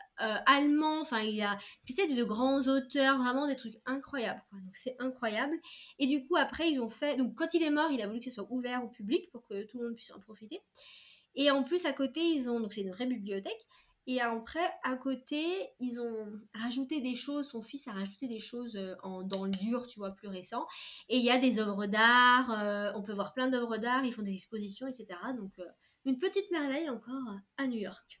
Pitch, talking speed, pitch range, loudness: 250 Hz, 235 wpm, 215-275 Hz, -33 LUFS